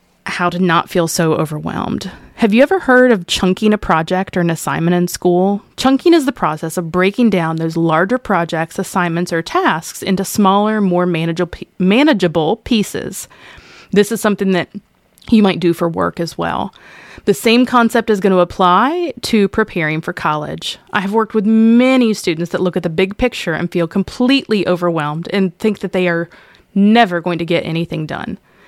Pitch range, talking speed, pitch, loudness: 170-220 Hz, 180 wpm, 185 Hz, -15 LUFS